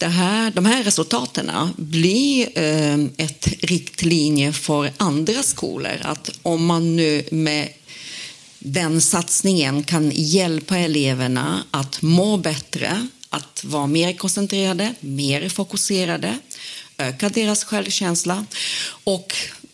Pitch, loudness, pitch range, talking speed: 170 Hz, -20 LUFS, 150-195 Hz, 100 wpm